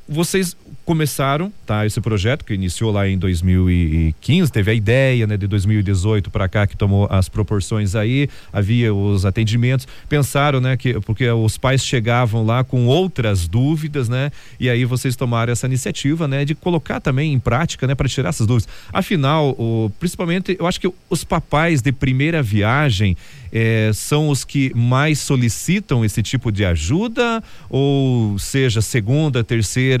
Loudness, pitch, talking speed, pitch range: -18 LUFS, 125 Hz, 160 wpm, 110-145 Hz